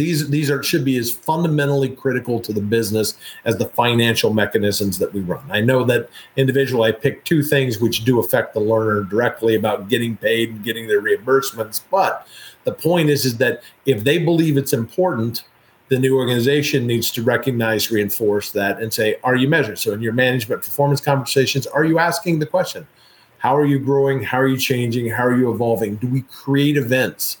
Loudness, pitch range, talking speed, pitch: -18 LUFS, 115-140 Hz, 195 wpm, 130 Hz